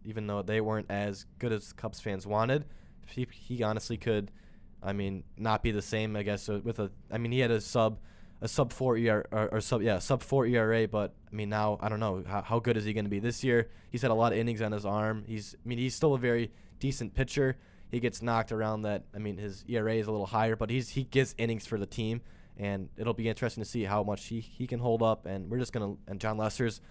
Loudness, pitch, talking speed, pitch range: -32 LUFS, 110 Hz, 265 wpm, 105-115 Hz